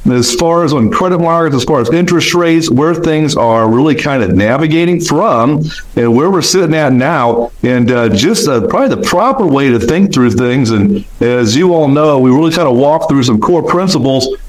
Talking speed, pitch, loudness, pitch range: 210 wpm, 150 Hz, -10 LUFS, 120-170 Hz